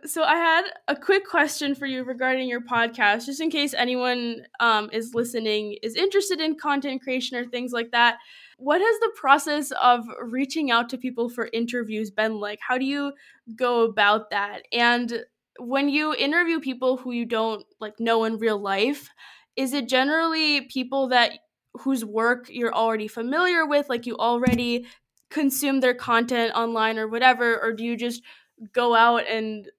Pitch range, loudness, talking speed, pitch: 230-280 Hz, -23 LUFS, 175 wpm, 245 Hz